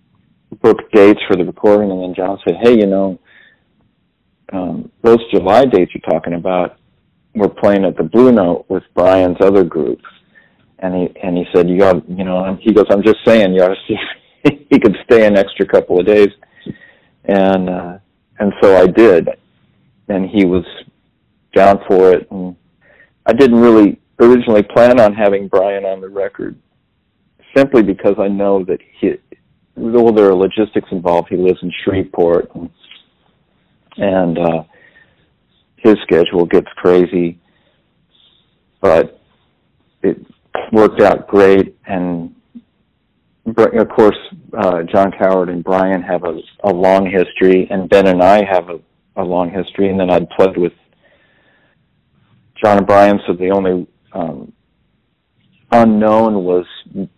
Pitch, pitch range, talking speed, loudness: 95 Hz, 90-105 Hz, 150 wpm, -12 LUFS